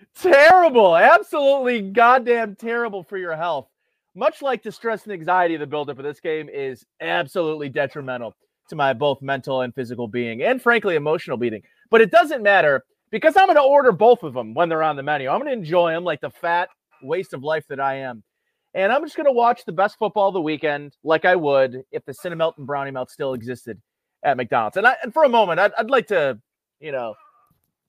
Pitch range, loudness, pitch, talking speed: 145-235 Hz, -19 LUFS, 175 Hz, 215 wpm